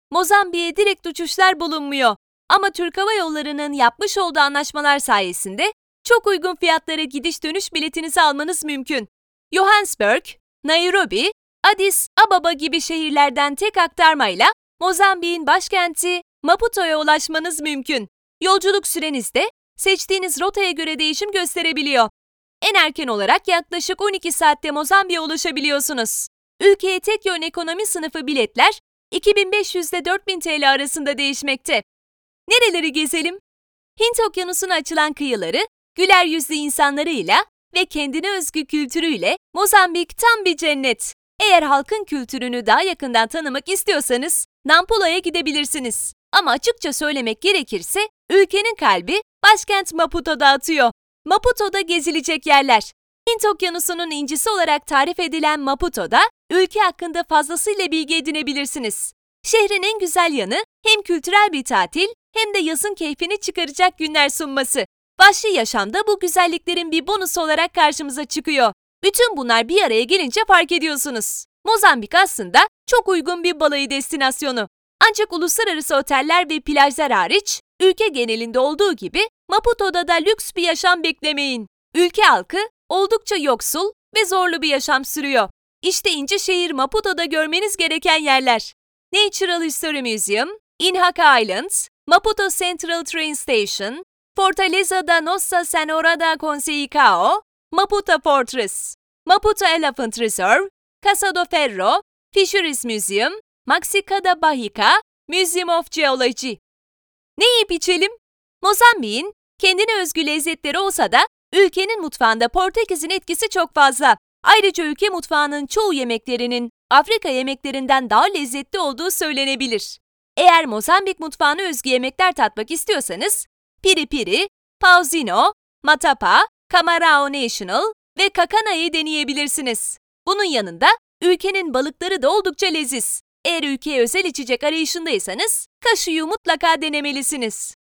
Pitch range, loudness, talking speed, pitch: 295-390 Hz, -17 LUFS, 115 wpm, 340 Hz